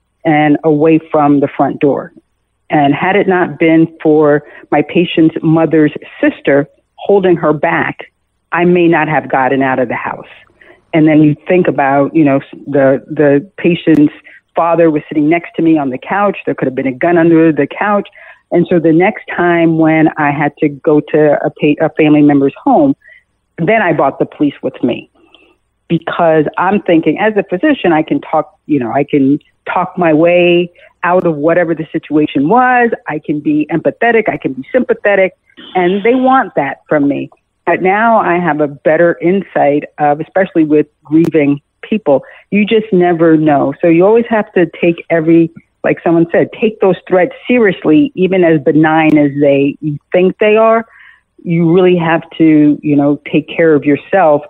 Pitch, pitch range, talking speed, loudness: 165 Hz, 150-180 Hz, 180 wpm, -11 LUFS